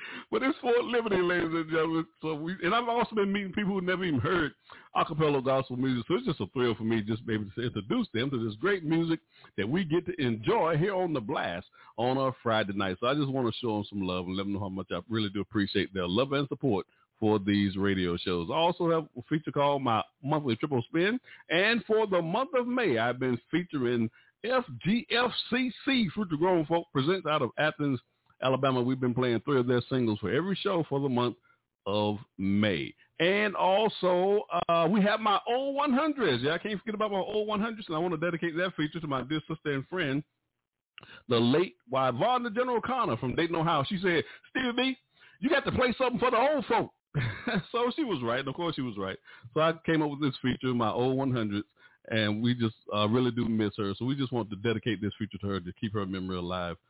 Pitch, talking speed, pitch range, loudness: 145 Hz, 230 wpm, 115-185 Hz, -29 LUFS